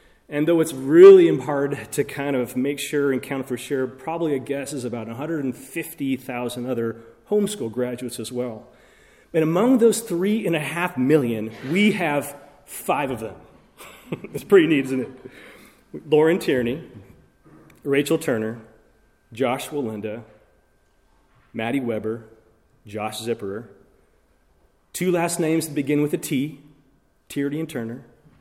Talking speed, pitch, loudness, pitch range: 135 wpm, 140 Hz, -22 LUFS, 120-160 Hz